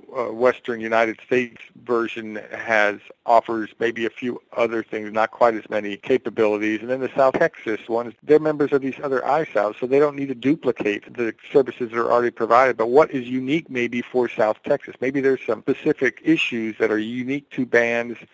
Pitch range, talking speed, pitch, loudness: 110-130 Hz, 190 wpm, 120 Hz, -21 LUFS